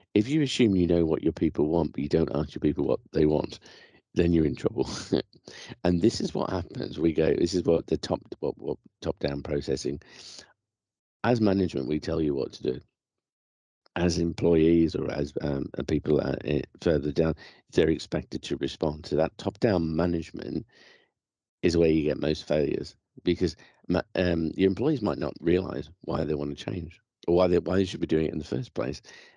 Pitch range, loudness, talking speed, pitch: 75-90 Hz, -27 LUFS, 195 wpm, 80 Hz